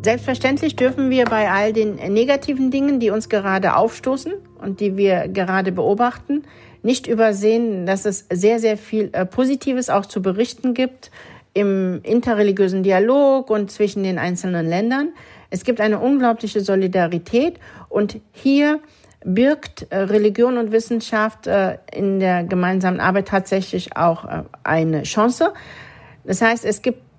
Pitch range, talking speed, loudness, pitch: 190-250 Hz, 130 wpm, -19 LUFS, 215 Hz